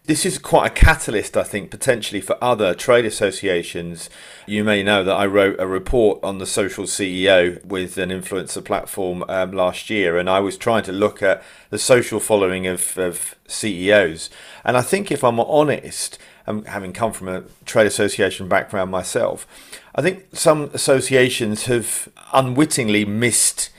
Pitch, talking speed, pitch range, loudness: 105 Hz, 165 wpm, 95-130 Hz, -19 LUFS